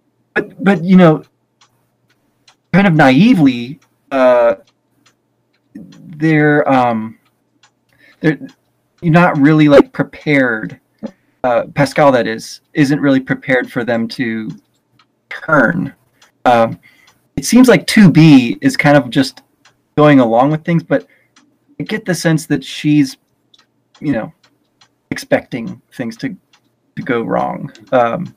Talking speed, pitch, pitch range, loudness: 120 wpm, 145 Hz, 130-170 Hz, -12 LUFS